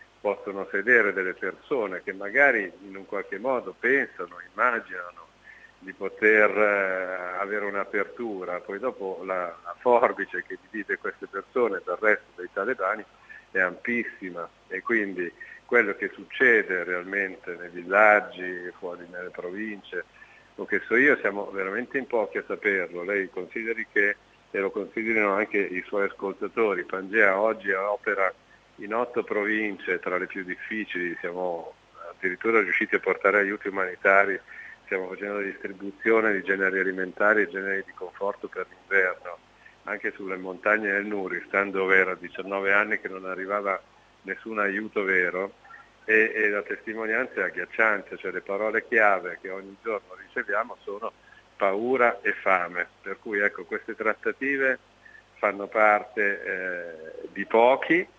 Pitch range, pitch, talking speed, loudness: 95-115 Hz, 100 Hz, 140 wpm, -26 LUFS